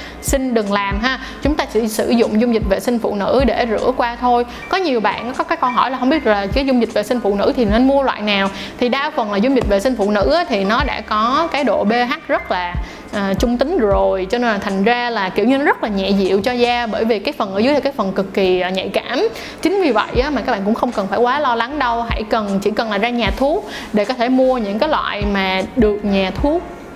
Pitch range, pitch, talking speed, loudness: 205-260 Hz, 235 Hz, 285 wpm, -17 LUFS